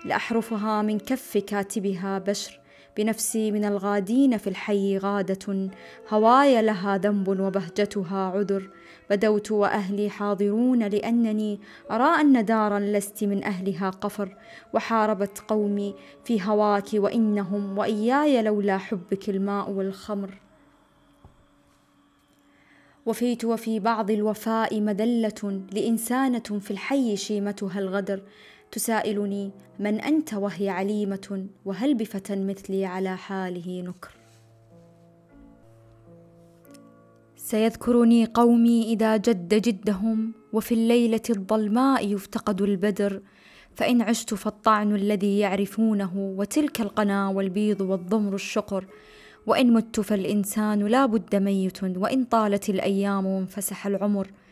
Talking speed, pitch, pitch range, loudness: 100 wpm, 205 Hz, 195-220 Hz, -25 LUFS